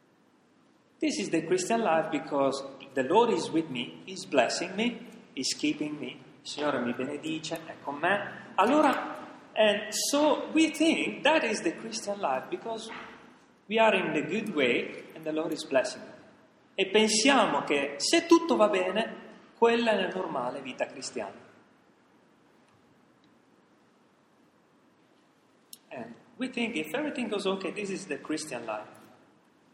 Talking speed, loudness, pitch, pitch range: 145 wpm, -28 LUFS, 215 Hz, 160-265 Hz